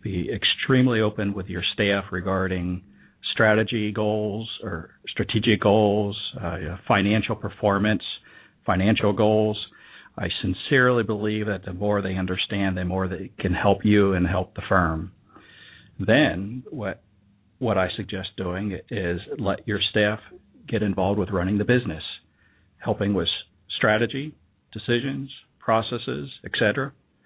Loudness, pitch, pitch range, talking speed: -24 LUFS, 105 Hz, 95-110 Hz, 125 wpm